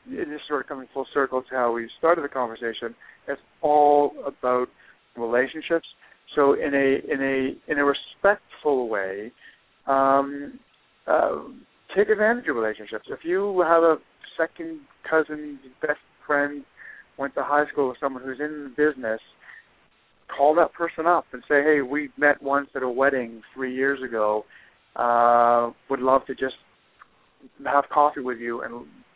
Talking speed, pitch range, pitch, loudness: 155 wpm, 125-150 Hz, 140 Hz, -24 LUFS